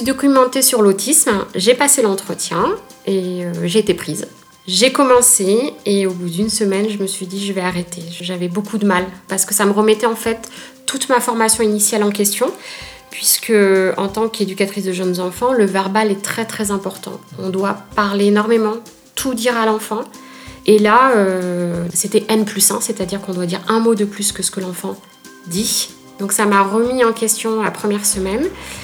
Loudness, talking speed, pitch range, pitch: -16 LUFS, 190 wpm, 190-225 Hz, 205 Hz